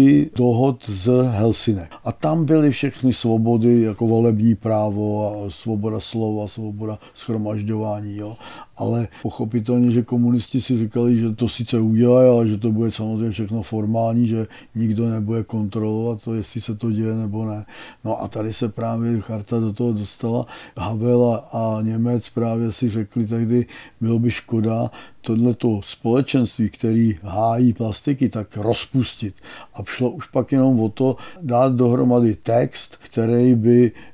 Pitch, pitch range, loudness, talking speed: 115 Hz, 110-120 Hz, -20 LUFS, 145 wpm